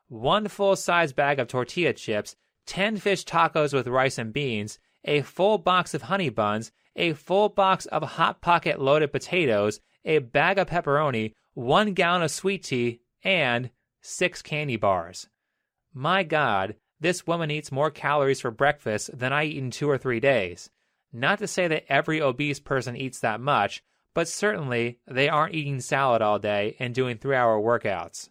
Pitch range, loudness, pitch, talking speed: 125-170 Hz, -25 LUFS, 145 Hz, 170 wpm